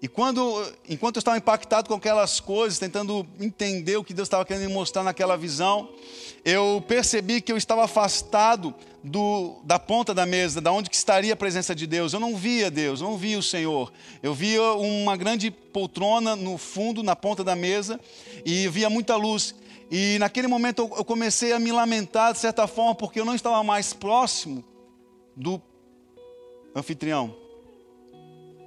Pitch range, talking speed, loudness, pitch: 180-225 Hz, 170 wpm, -24 LUFS, 205 Hz